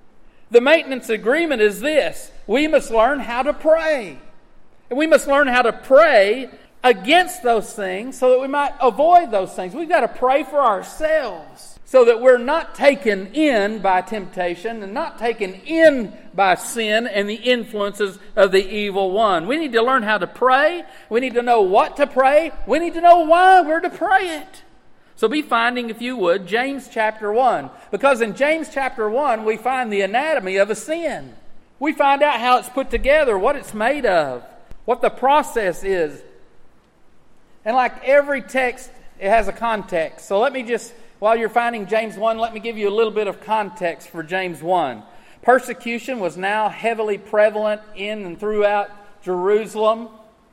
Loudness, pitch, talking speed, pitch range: -18 LUFS, 235 Hz, 180 wpm, 210-280 Hz